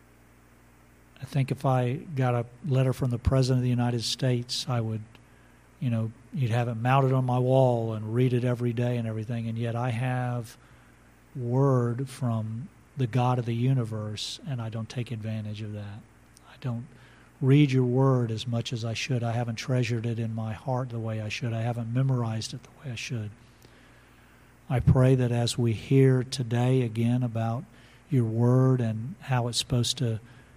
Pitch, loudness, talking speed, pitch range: 120 Hz, -27 LUFS, 185 wpm, 115-130 Hz